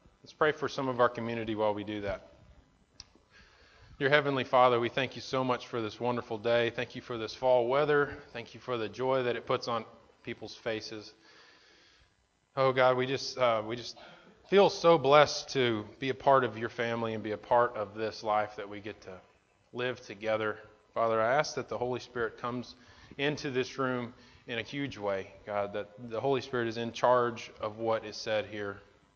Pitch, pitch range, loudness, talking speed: 120 Hz, 110-130 Hz, -31 LUFS, 200 wpm